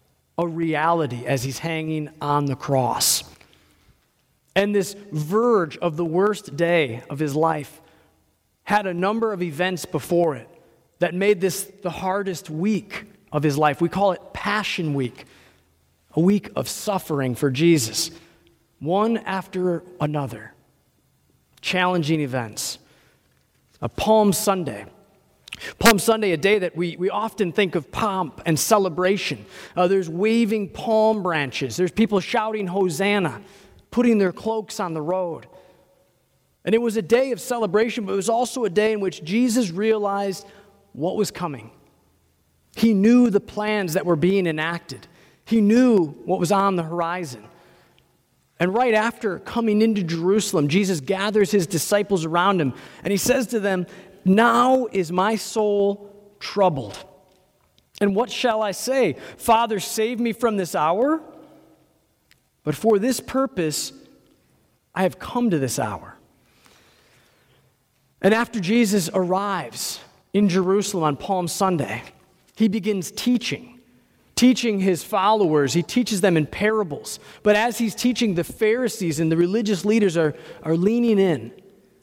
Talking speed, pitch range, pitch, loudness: 140 wpm, 165-215 Hz, 190 Hz, -22 LUFS